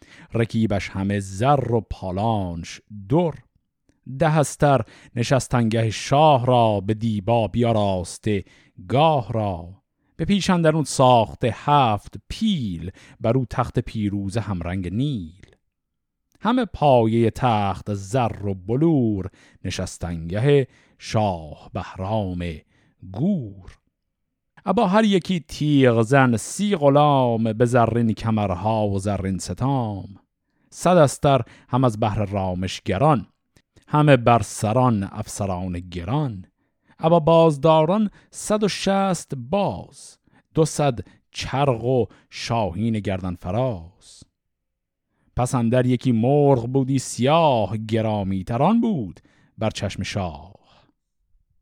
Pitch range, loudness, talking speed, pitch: 100-140 Hz, -21 LUFS, 100 wpm, 115 Hz